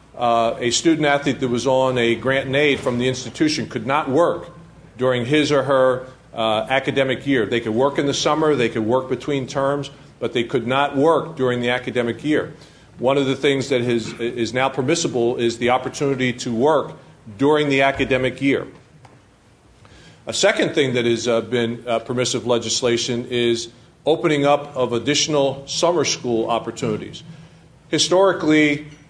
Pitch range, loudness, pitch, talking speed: 120-145 Hz, -19 LUFS, 130 Hz, 165 wpm